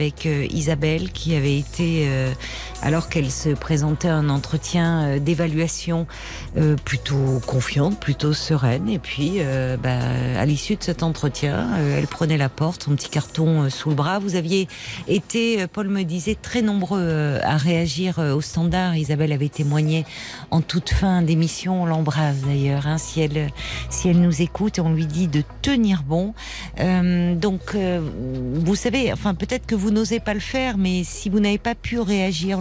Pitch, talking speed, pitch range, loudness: 160 Hz, 165 wpm, 145-185 Hz, -22 LUFS